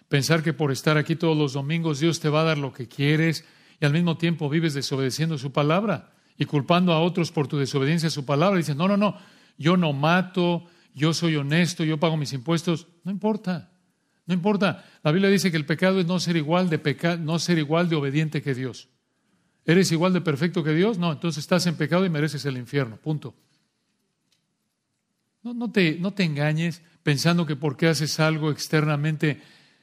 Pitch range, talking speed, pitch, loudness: 150-175 Hz, 200 wpm, 160 Hz, -24 LUFS